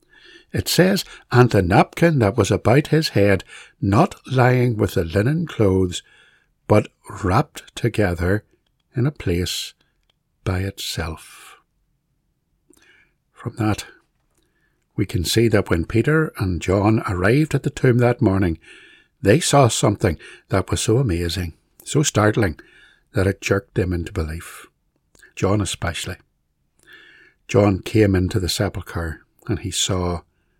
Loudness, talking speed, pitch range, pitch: -20 LUFS, 125 wpm, 95-125 Hz, 105 Hz